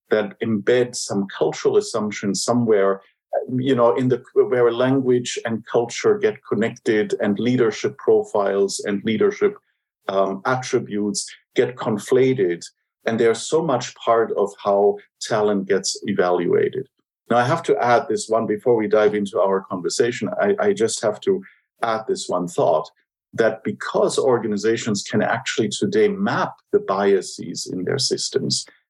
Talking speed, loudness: 145 wpm, -21 LUFS